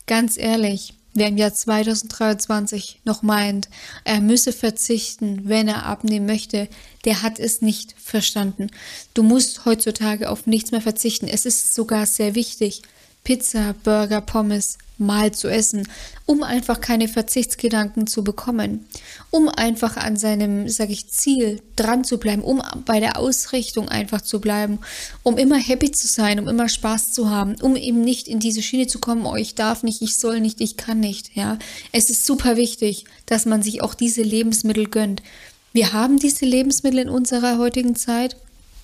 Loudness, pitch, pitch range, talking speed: -20 LUFS, 225 Hz, 215-240 Hz, 170 wpm